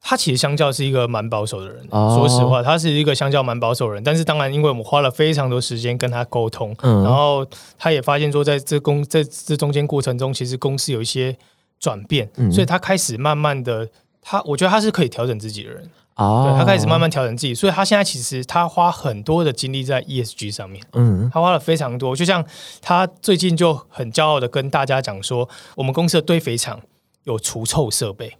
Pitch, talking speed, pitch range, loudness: 135 Hz, 335 characters per minute, 120-155 Hz, -18 LUFS